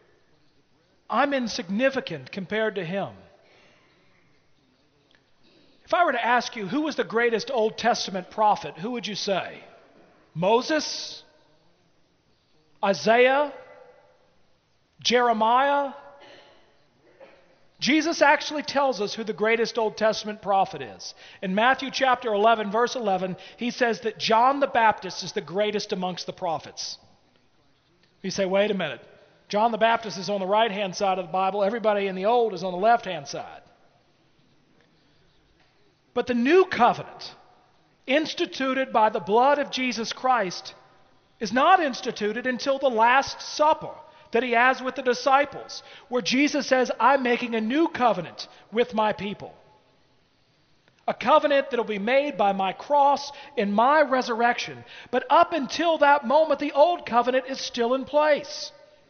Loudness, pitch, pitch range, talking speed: -24 LUFS, 235 Hz, 210-275 Hz, 140 wpm